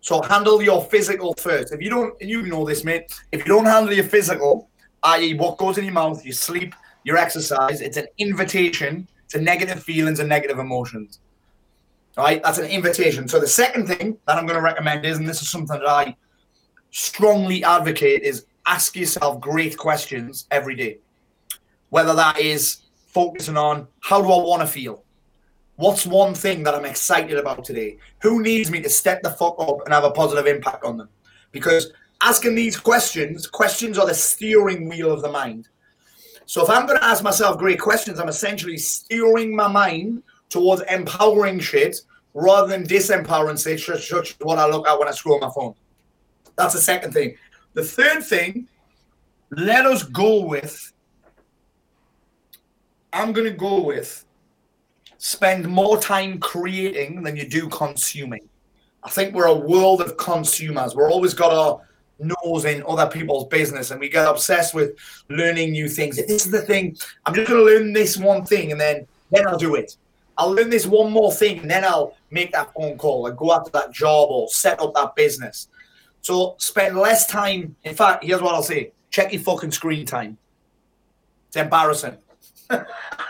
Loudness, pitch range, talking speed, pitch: -19 LUFS, 150-205 Hz, 180 wpm, 175 Hz